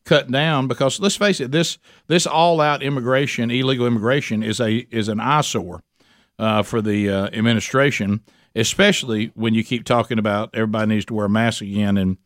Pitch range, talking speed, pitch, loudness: 110-135 Hz, 180 wpm, 115 Hz, -19 LUFS